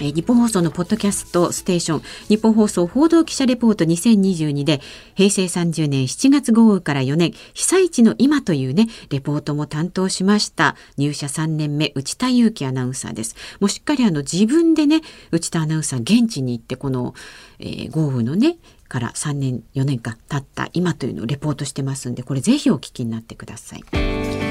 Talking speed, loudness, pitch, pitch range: 350 characters per minute, -19 LUFS, 165 Hz, 135-215 Hz